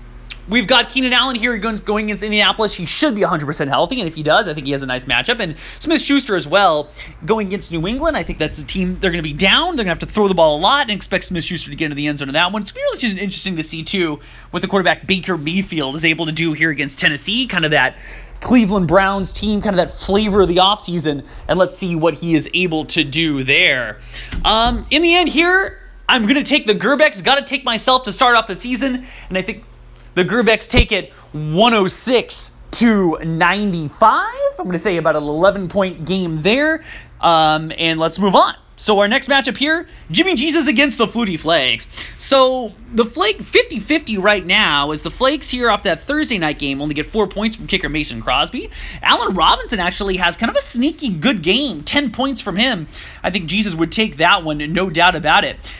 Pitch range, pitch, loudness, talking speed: 165-240 Hz, 195 Hz, -16 LUFS, 225 wpm